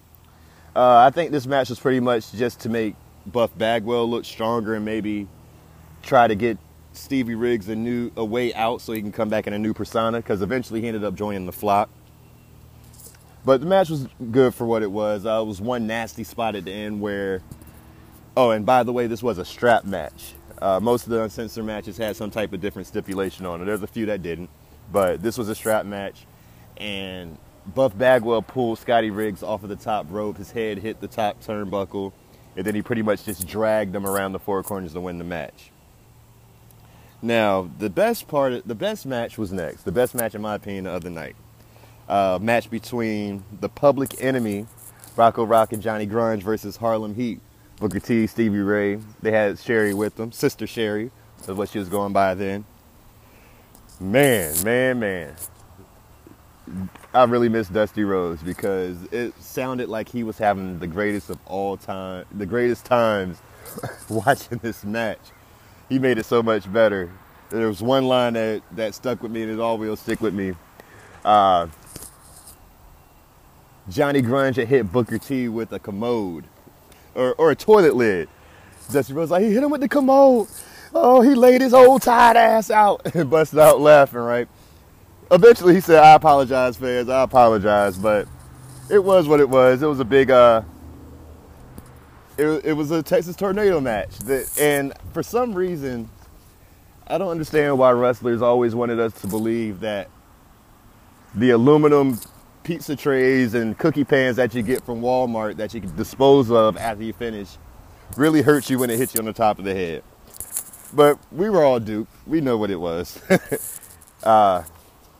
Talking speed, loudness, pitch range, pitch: 185 wpm, -20 LUFS, 100-125 Hz, 110 Hz